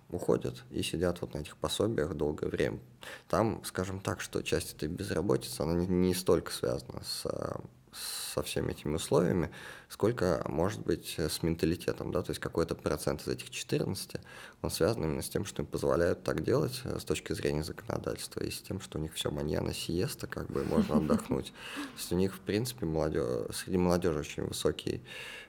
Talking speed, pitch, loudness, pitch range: 180 wpm, 85 Hz, -33 LUFS, 75-95 Hz